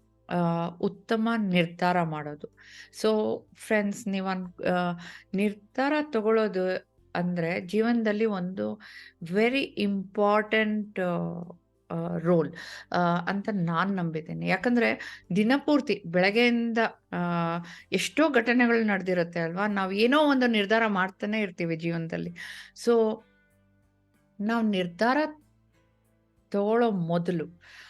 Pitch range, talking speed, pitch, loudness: 170-220 Hz, 75 wpm, 190 Hz, -27 LUFS